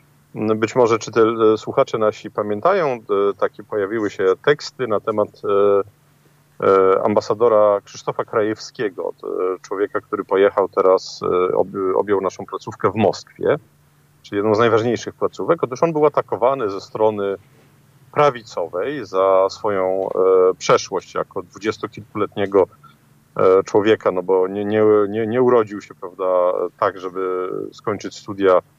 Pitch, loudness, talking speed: 115 Hz, -19 LUFS, 115 wpm